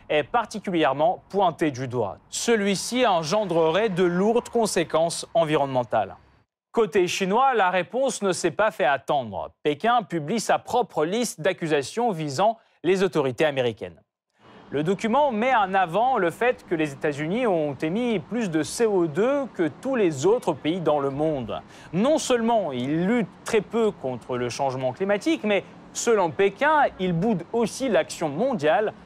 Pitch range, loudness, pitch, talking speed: 155-230 Hz, -24 LUFS, 190 Hz, 145 wpm